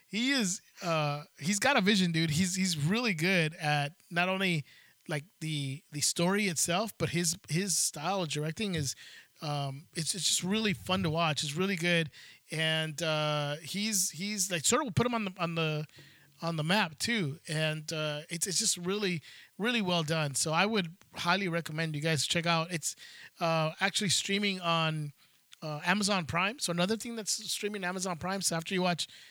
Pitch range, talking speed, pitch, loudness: 155-195 Hz, 190 wpm, 170 Hz, -31 LUFS